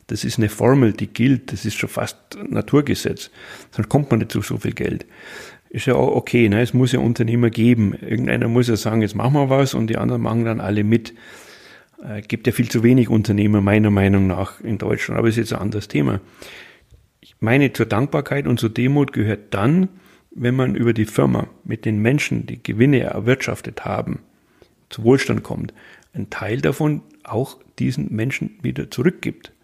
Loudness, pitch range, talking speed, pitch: -19 LUFS, 105-125 Hz, 195 wpm, 115 Hz